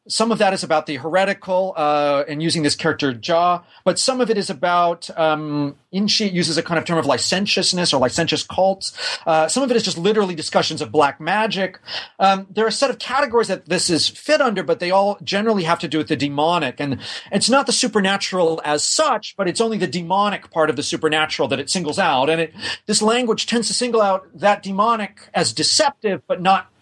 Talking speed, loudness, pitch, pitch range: 225 wpm, -19 LUFS, 185 Hz, 160-210 Hz